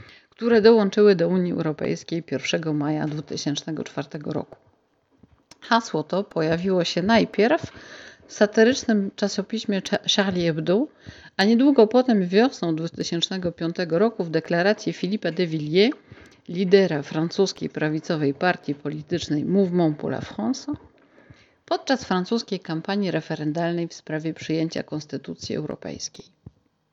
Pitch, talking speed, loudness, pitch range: 180 Hz, 105 wpm, -23 LUFS, 160-210 Hz